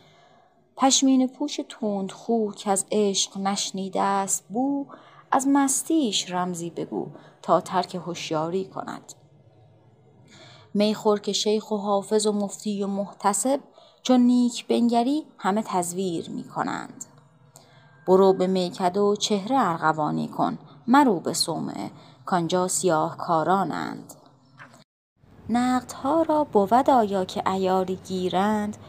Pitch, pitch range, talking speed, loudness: 195 Hz, 180-235 Hz, 110 wpm, -24 LUFS